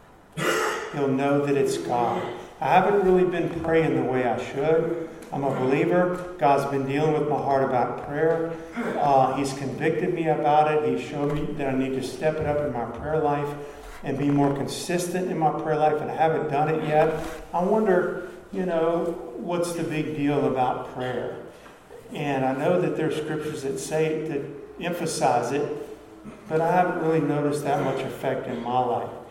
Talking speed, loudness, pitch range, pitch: 190 wpm, -25 LUFS, 140-165 Hz, 150 Hz